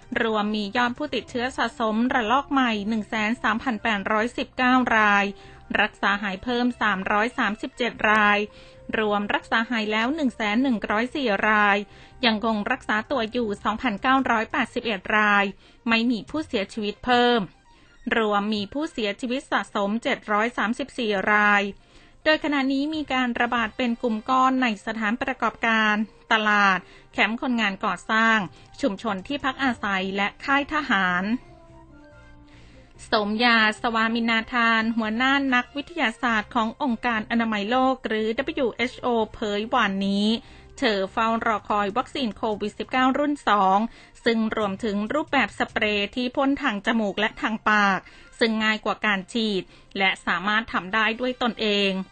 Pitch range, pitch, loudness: 210-250 Hz, 225 Hz, -23 LUFS